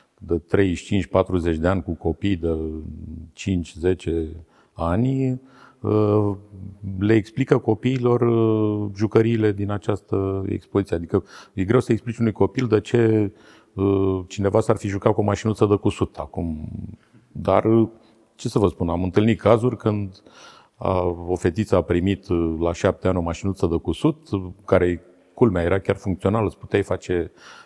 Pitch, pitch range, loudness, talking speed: 100 Hz, 90-110 Hz, -22 LUFS, 135 wpm